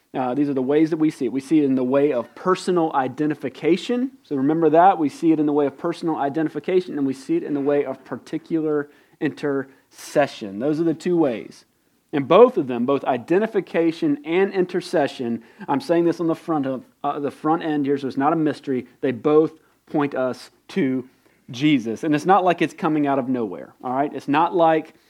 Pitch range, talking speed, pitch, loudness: 135-165 Hz, 215 wpm, 150 Hz, -21 LUFS